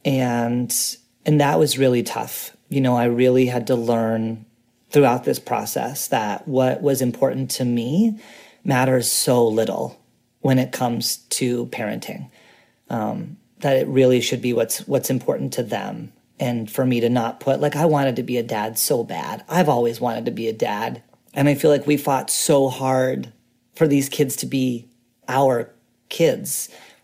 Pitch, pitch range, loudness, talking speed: 125 Hz, 120-135 Hz, -20 LUFS, 175 wpm